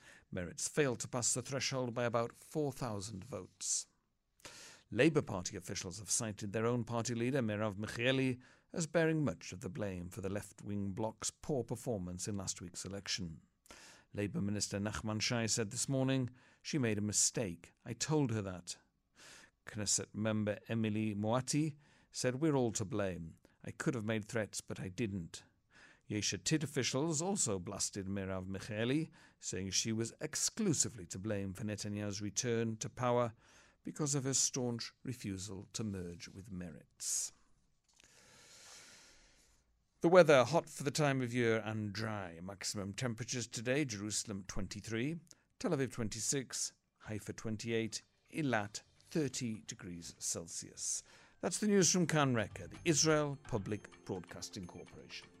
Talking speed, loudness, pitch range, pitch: 140 wpm, -37 LUFS, 100-130 Hz, 110 Hz